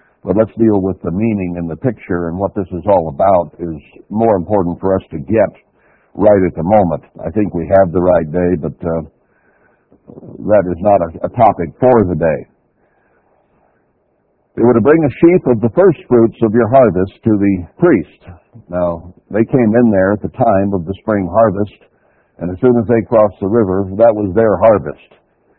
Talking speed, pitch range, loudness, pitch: 195 wpm, 90-115 Hz, -13 LUFS, 100 Hz